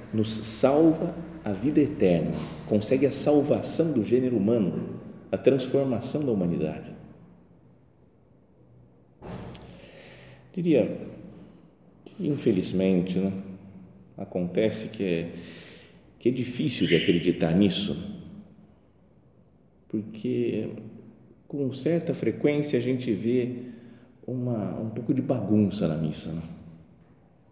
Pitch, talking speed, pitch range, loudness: 120 Hz, 95 wpm, 95-130 Hz, -26 LUFS